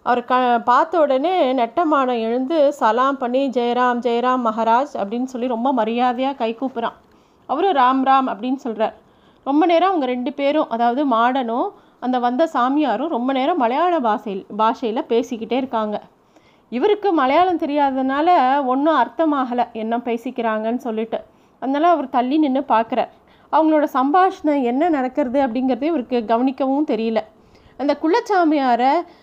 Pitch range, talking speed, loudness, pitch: 235-295 Hz, 125 wpm, -19 LUFS, 260 Hz